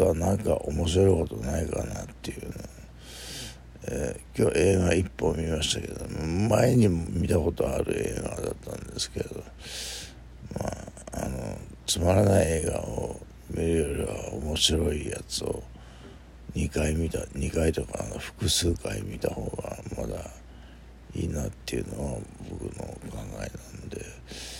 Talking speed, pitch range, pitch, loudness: 270 characters per minute, 70-90 Hz, 80 Hz, -28 LUFS